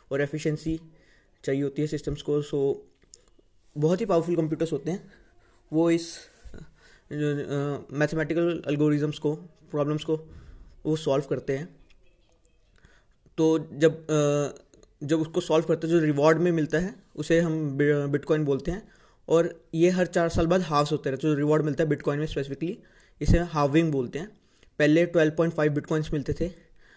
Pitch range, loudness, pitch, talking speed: 145-165 Hz, -26 LUFS, 155 Hz, 150 wpm